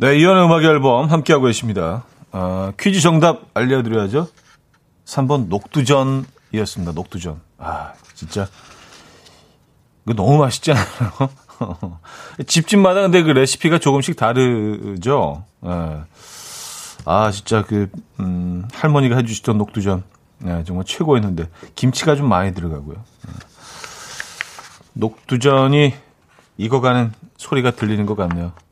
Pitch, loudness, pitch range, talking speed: 120 Hz, -17 LUFS, 95-140 Hz, 255 characters per minute